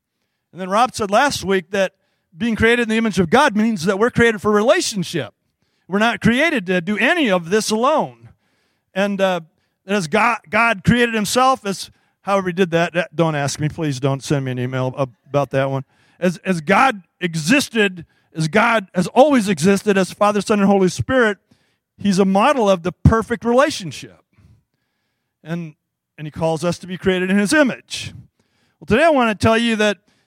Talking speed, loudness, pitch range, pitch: 185 wpm, -17 LUFS, 170-225 Hz, 195 Hz